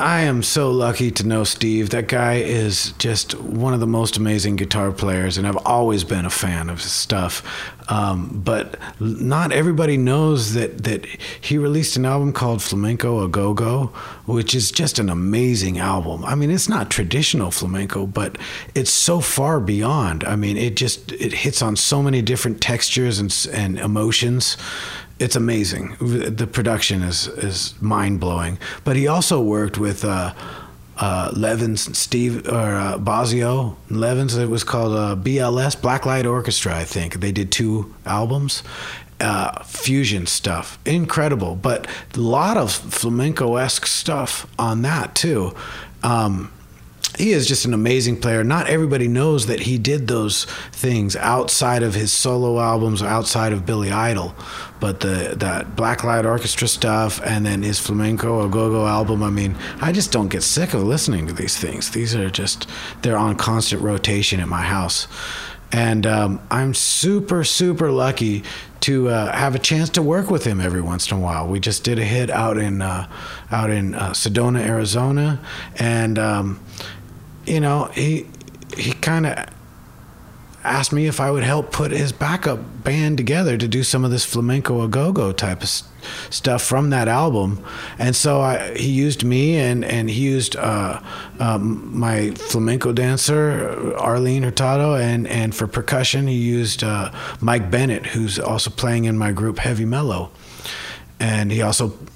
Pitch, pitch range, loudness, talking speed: 115 Hz, 105-130 Hz, -19 LUFS, 170 wpm